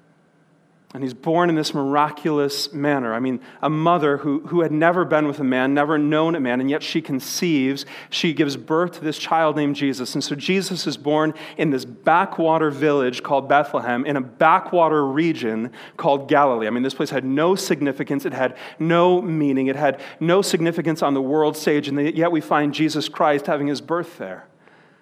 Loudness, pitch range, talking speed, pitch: -20 LUFS, 140-165 Hz, 195 wpm, 150 Hz